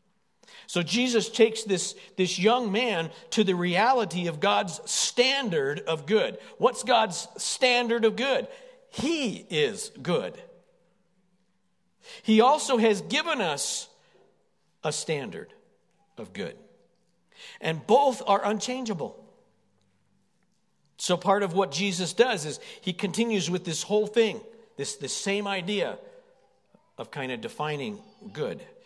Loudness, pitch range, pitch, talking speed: -26 LUFS, 185-245 Hz, 210 Hz, 125 wpm